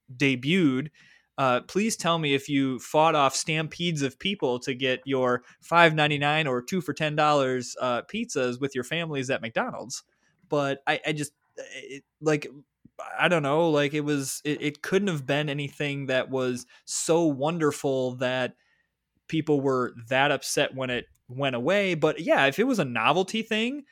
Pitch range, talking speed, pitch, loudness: 130-165 Hz, 170 wpm, 145 Hz, -26 LUFS